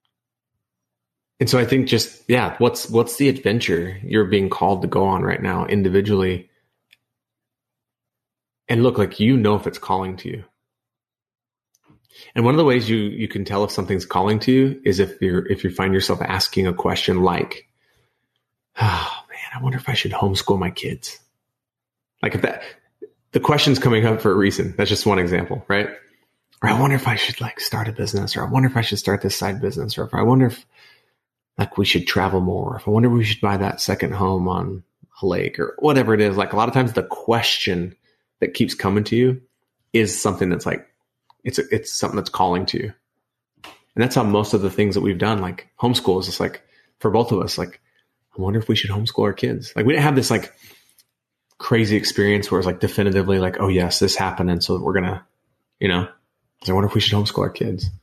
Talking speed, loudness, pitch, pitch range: 215 wpm, -20 LUFS, 110 Hz, 95-125 Hz